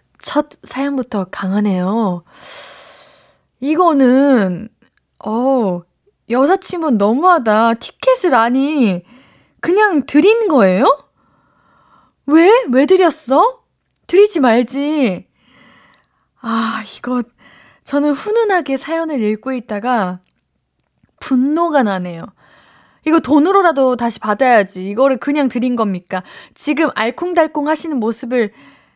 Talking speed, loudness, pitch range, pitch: 210 characters per minute, -15 LUFS, 225-315 Hz, 265 Hz